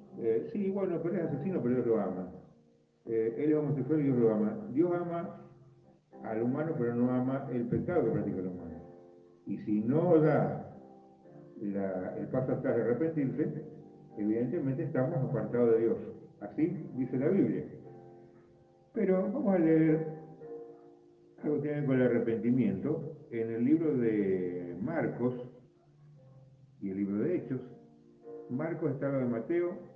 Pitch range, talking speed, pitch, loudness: 110-155 Hz, 155 wpm, 130 Hz, -32 LUFS